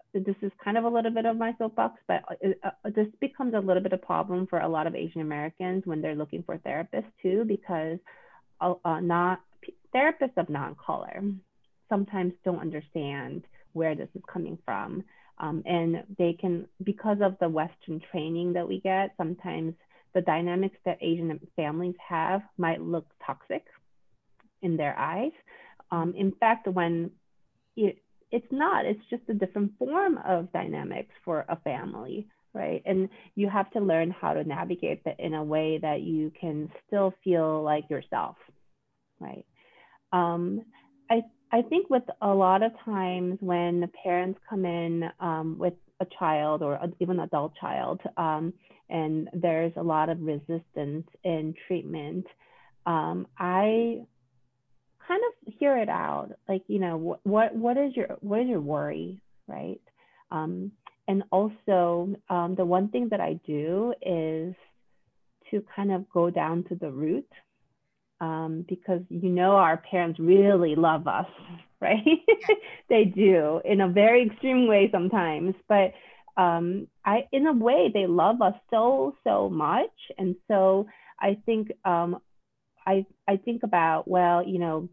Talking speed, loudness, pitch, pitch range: 155 wpm, -27 LUFS, 185 Hz, 165-210 Hz